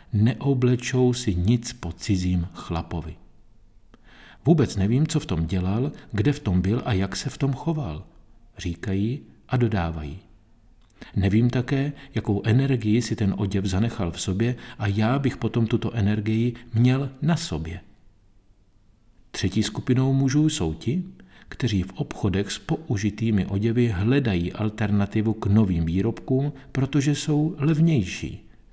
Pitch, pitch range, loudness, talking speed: 110 Hz, 100-130 Hz, -24 LUFS, 130 wpm